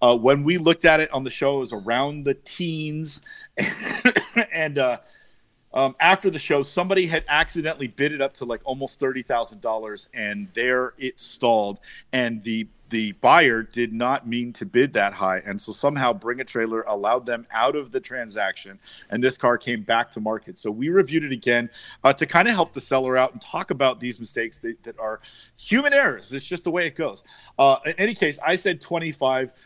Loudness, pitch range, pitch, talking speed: -22 LUFS, 115-160 Hz, 130 Hz, 210 wpm